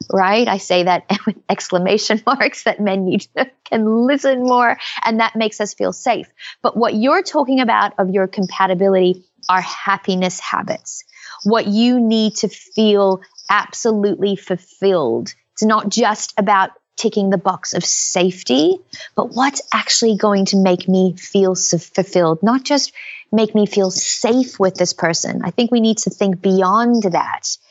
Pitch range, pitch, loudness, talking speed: 190-230 Hz, 205 Hz, -16 LUFS, 160 wpm